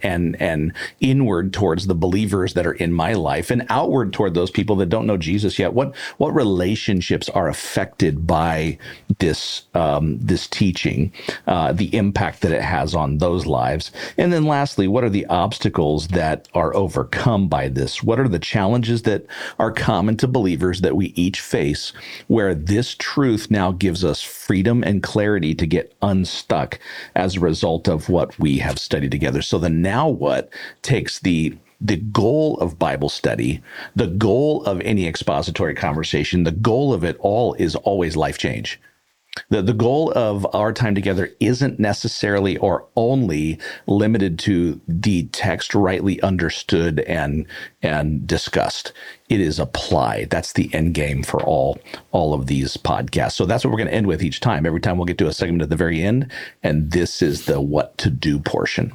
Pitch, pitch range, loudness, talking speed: 90 Hz, 80-105 Hz, -20 LUFS, 180 wpm